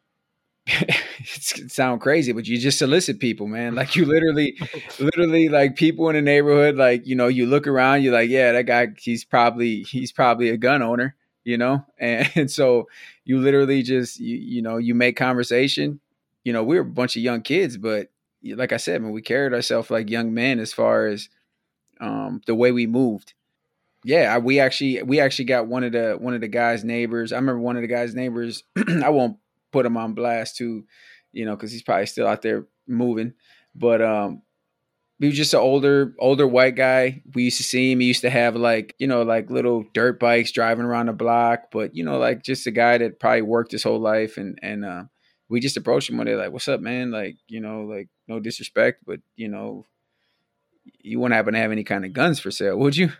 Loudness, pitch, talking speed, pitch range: -21 LUFS, 120 Hz, 220 wpm, 115-130 Hz